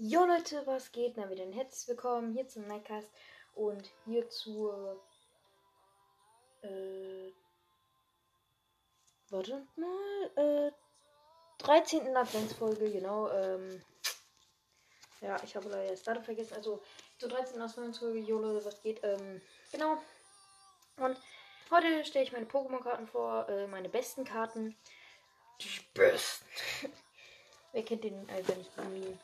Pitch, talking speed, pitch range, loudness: 220 Hz, 125 wpm, 190-265 Hz, -36 LUFS